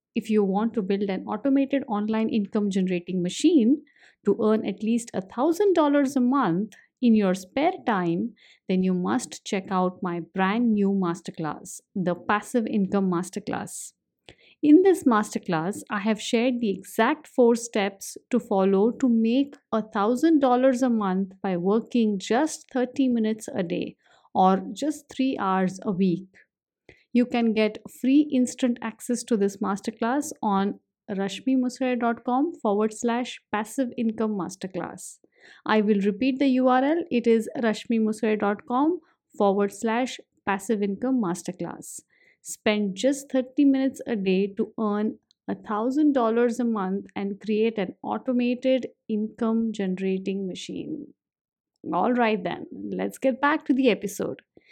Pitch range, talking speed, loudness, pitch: 200-255 Hz, 135 wpm, -25 LUFS, 225 Hz